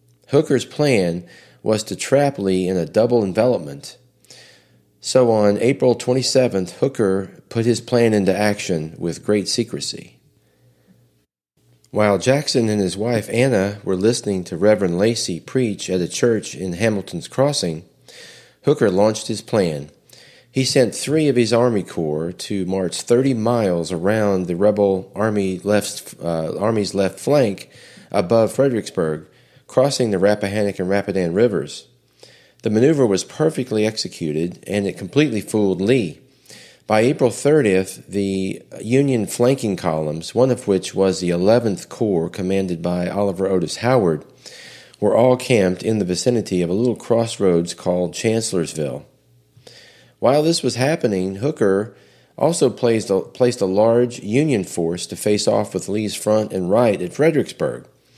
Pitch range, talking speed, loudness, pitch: 90-120 Hz, 140 wpm, -19 LUFS, 100 Hz